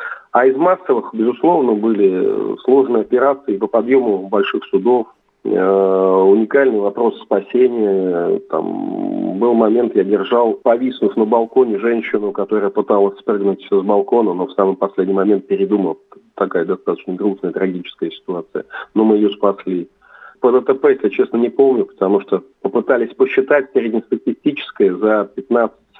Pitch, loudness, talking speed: 110 Hz, -16 LUFS, 130 wpm